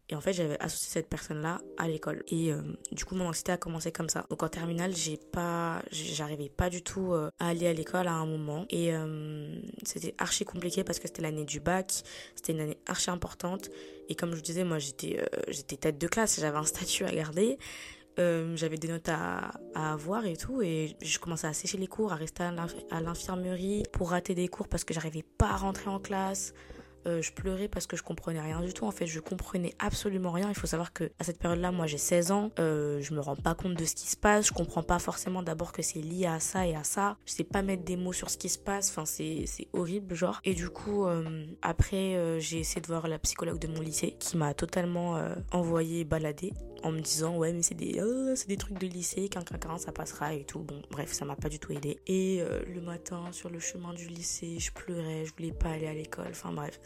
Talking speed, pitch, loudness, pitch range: 250 wpm, 170 Hz, -33 LUFS, 160-185 Hz